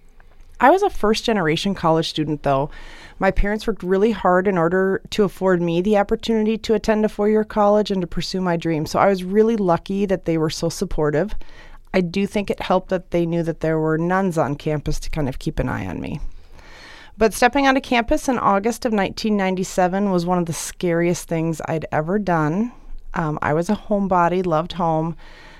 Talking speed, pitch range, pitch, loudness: 205 wpm, 165-210 Hz, 185 Hz, -20 LUFS